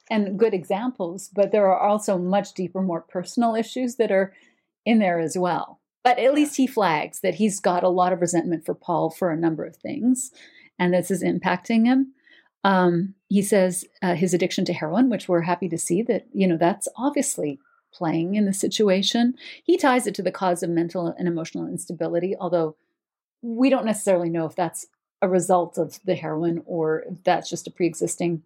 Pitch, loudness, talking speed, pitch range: 185 Hz, -23 LUFS, 200 wpm, 175-225 Hz